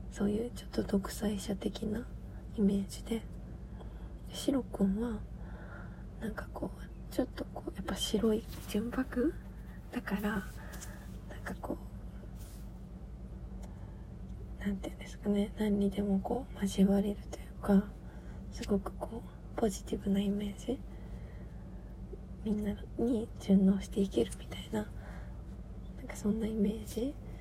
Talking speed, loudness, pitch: 250 characters per minute, -35 LUFS, 200 Hz